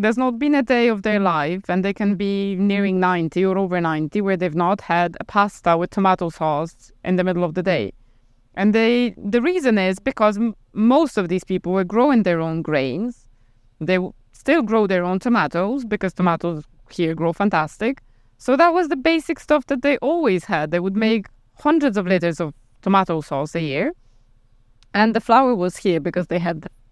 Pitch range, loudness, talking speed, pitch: 165-220 Hz, -20 LUFS, 200 wpm, 185 Hz